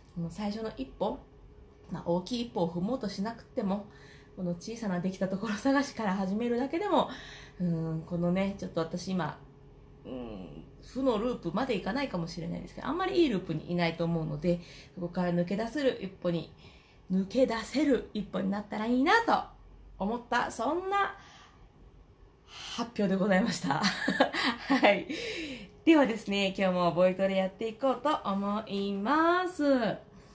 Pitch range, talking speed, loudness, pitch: 175-240 Hz, 315 characters per minute, -30 LUFS, 200 Hz